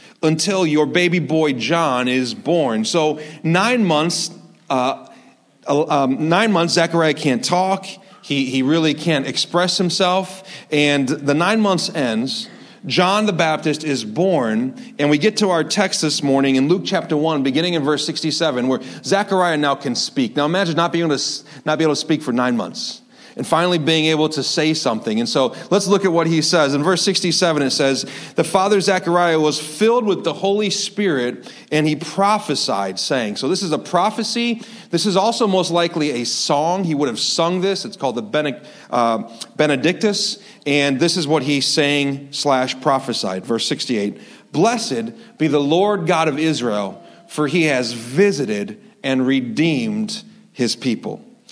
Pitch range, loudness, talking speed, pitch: 145-195 Hz, -18 LUFS, 170 wpm, 165 Hz